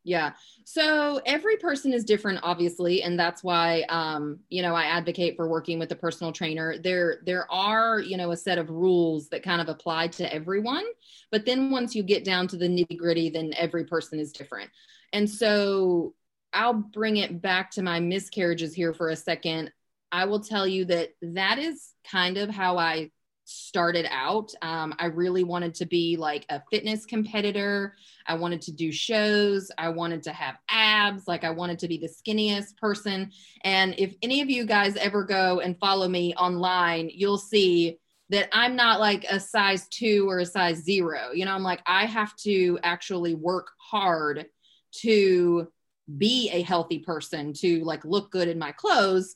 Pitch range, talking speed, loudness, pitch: 170-205 Hz, 185 wpm, -26 LUFS, 180 Hz